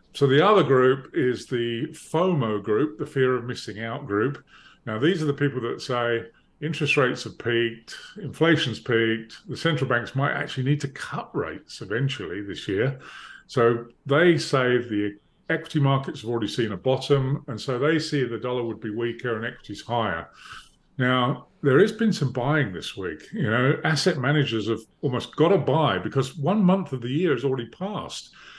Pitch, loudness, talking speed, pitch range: 130 Hz, -24 LUFS, 185 wpm, 115-150 Hz